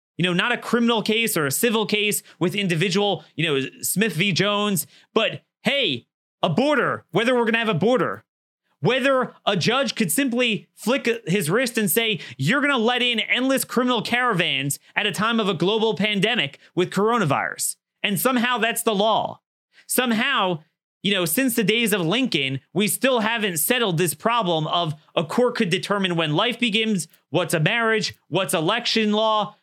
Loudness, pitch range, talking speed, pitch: -21 LUFS, 180-235 Hz, 175 wpm, 210 Hz